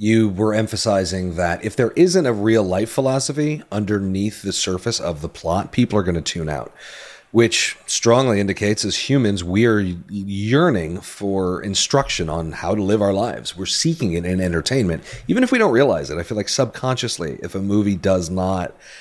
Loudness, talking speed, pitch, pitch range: -19 LUFS, 185 wpm, 105 Hz, 95-115 Hz